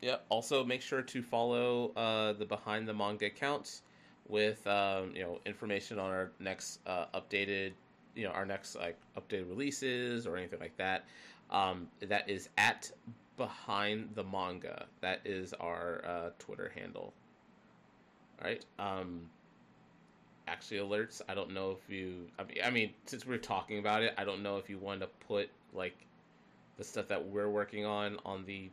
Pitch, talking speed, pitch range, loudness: 100 Hz, 170 wpm, 95-105 Hz, -38 LUFS